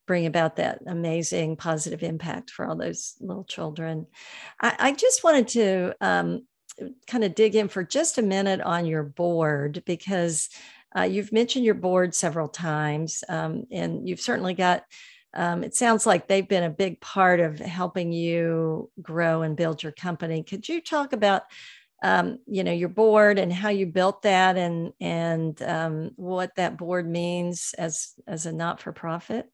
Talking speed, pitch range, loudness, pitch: 170 wpm, 165-195 Hz, -25 LUFS, 180 Hz